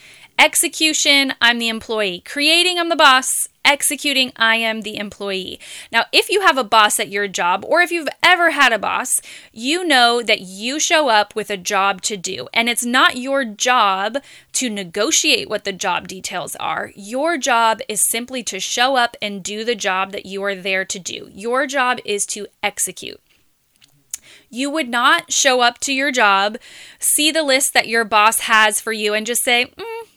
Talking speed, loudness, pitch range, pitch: 190 wpm, -16 LUFS, 205-285 Hz, 240 Hz